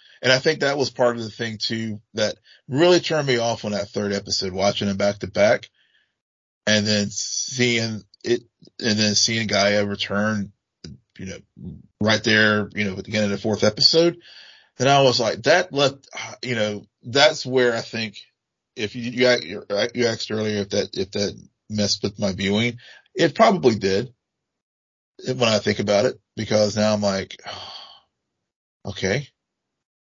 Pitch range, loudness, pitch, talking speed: 100-125 Hz, -21 LUFS, 110 Hz, 170 wpm